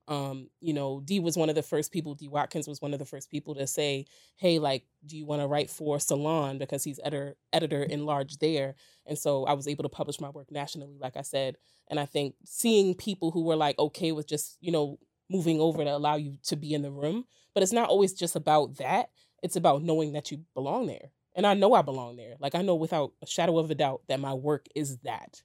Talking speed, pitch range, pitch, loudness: 250 wpm, 140-160 Hz, 150 Hz, -30 LUFS